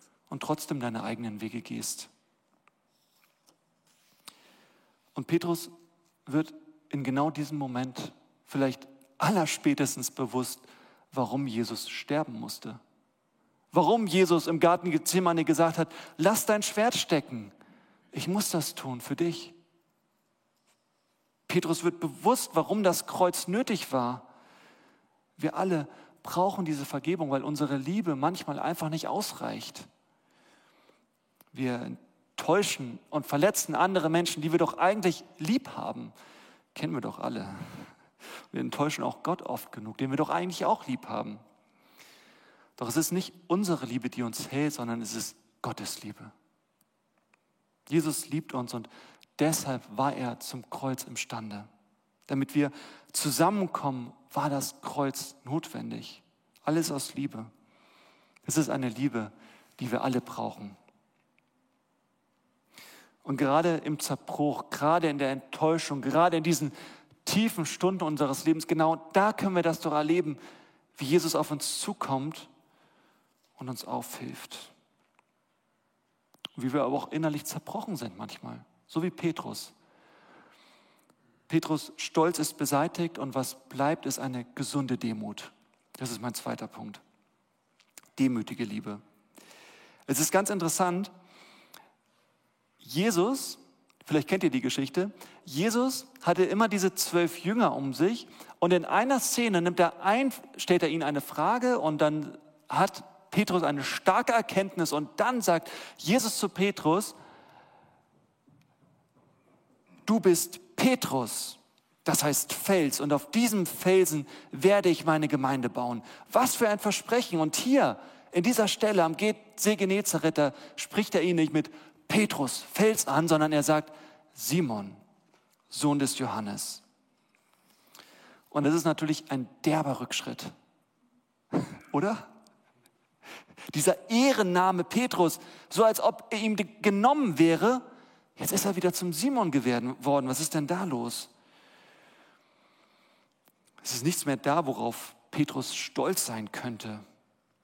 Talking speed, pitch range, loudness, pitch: 125 wpm, 135-185 Hz, -29 LUFS, 160 Hz